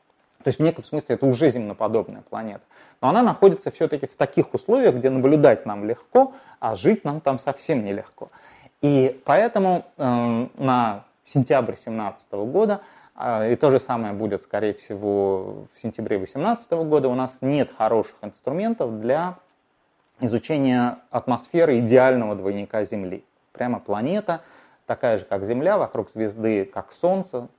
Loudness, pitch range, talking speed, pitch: -22 LUFS, 115-165 Hz, 145 wpm, 130 Hz